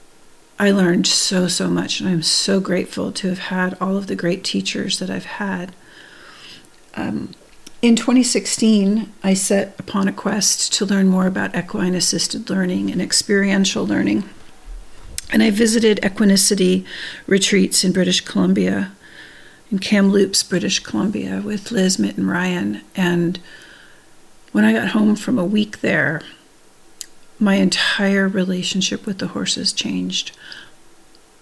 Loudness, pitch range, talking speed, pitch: -18 LUFS, 180-205 Hz, 135 wpm, 195 Hz